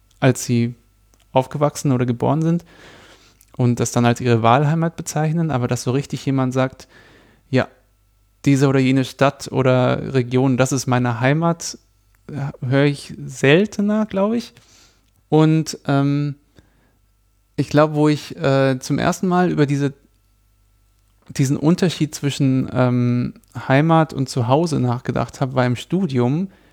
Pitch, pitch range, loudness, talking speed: 135 Hz, 120-150 Hz, -19 LUFS, 130 wpm